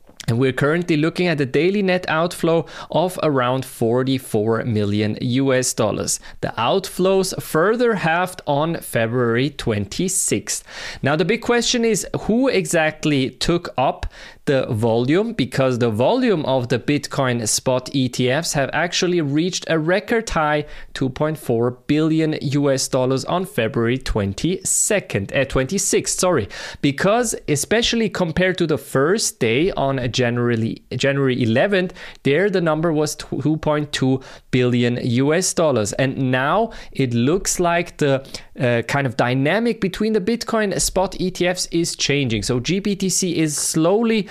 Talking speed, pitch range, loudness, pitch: 135 wpm, 130-180 Hz, -19 LUFS, 150 Hz